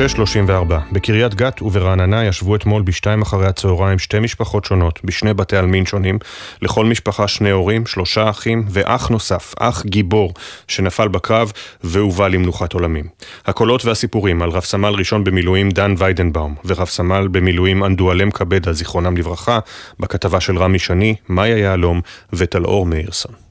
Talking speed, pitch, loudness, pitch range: 140 wpm, 100 Hz, -16 LUFS, 90-105 Hz